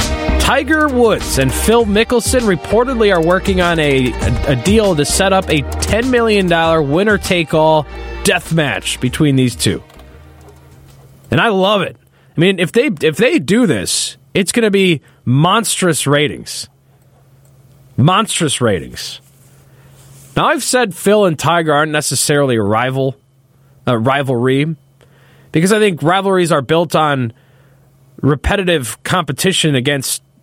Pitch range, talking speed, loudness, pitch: 135-185 Hz, 135 wpm, -14 LUFS, 145 Hz